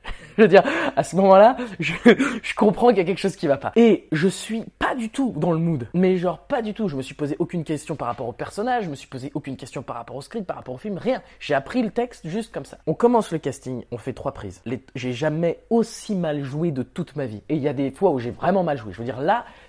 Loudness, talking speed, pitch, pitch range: -22 LUFS, 295 wpm, 170 Hz, 140-215 Hz